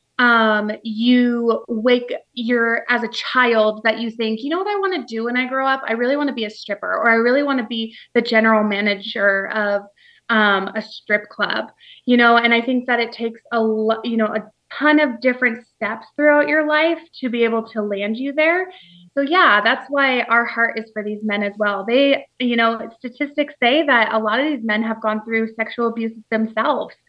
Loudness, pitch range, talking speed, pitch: -18 LUFS, 220-255 Hz, 215 wpm, 230 Hz